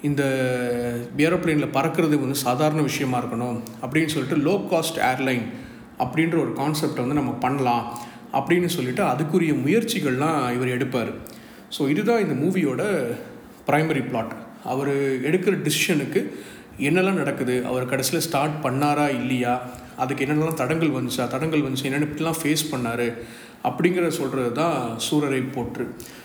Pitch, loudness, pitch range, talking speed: 140 Hz, -23 LUFS, 125-160 Hz, 125 wpm